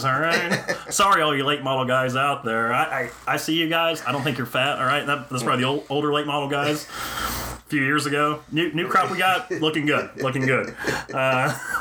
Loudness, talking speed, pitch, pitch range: -22 LUFS, 235 wpm, 145 Hz, 135-155 Hz